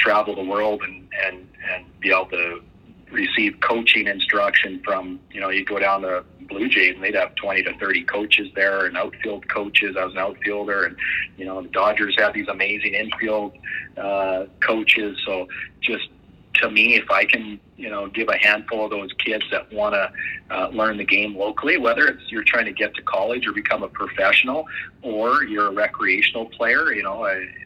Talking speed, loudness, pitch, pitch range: 195 wpm, -20 LUFS, 100 Hz, 95-105 Hz